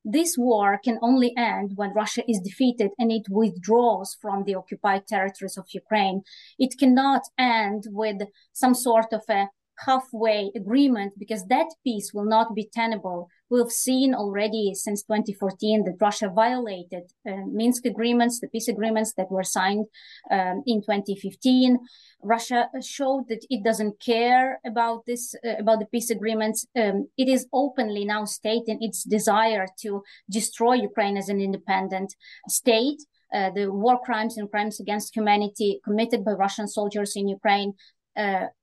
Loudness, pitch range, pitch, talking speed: -24 LUFS, 200-240 Hz, 220 Hz, 150 wpm